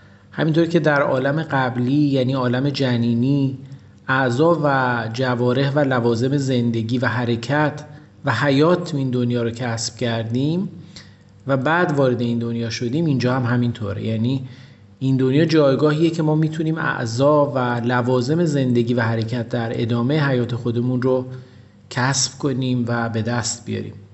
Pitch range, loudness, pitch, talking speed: 120-140 Hz, -20 LUFS, 130 Hz, 140 wpm